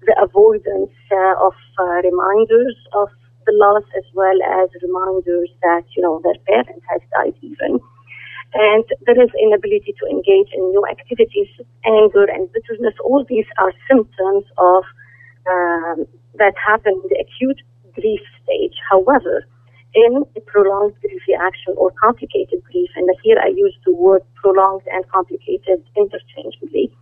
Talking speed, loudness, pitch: 145 wpm, -16 LUFS, 200 Hz